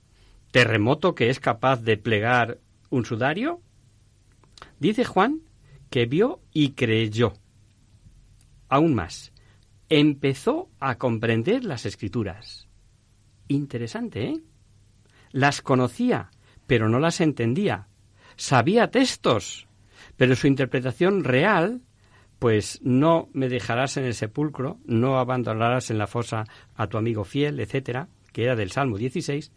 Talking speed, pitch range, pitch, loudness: 115 wpm, 110-140 Hz, 120 Hz, -24 LUFS